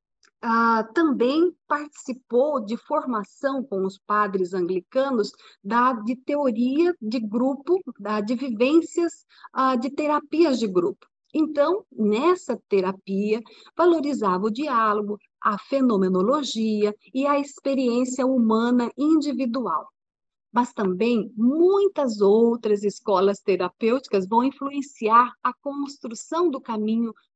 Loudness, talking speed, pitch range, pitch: -23 LUFS, 105 wpm, 215-285 Hz, 245 Hz